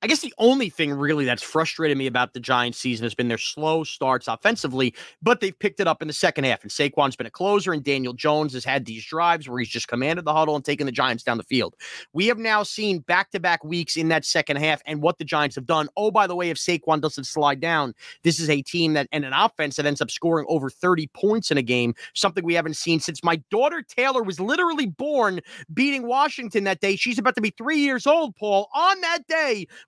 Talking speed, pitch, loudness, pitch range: 250 wpm, 160 Hz, -23 LUFS, 140-205 Hz